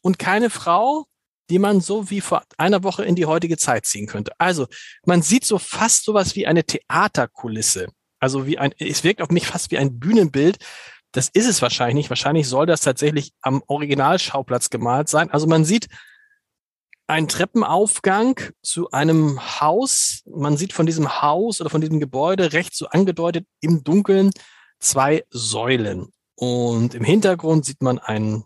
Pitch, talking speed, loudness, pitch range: 160 Hz, 165 wpm, -19 LUFS, 135-190 Hz